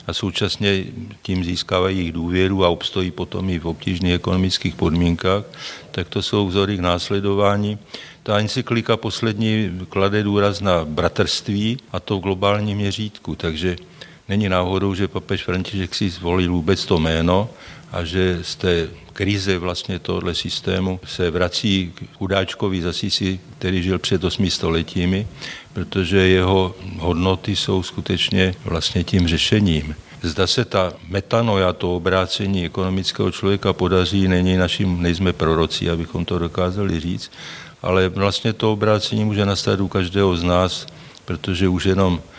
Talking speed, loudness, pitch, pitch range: 140 wpm, -20 LUFS, 95 Hz, 90-100 Hz